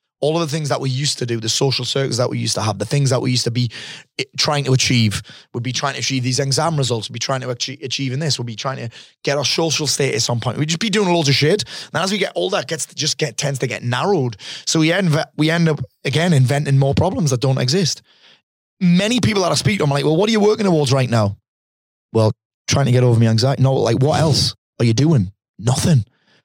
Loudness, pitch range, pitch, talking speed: -18 LUFS, 125-155 Hz, 135 Hz, 265 wpm